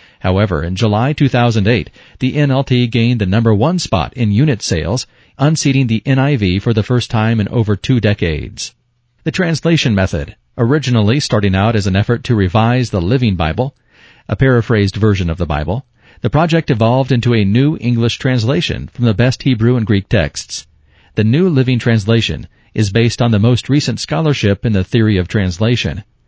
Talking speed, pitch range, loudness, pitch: 175 wpm, 100-130 Hz, -14 LUFS, 115 Hz